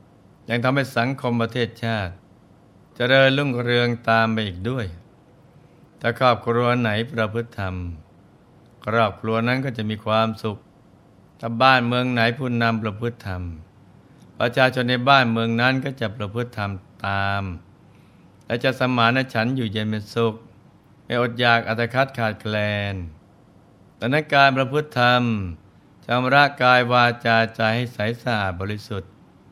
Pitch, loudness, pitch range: 115 Hz, -21 LUFS, 105-125 Hz